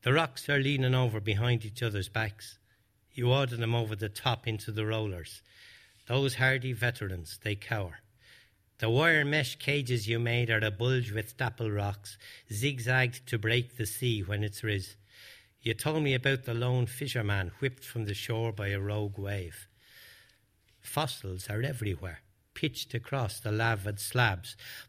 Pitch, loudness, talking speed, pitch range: 115 Hz, -31 LUFS, 160 wpm, 105-125 Hz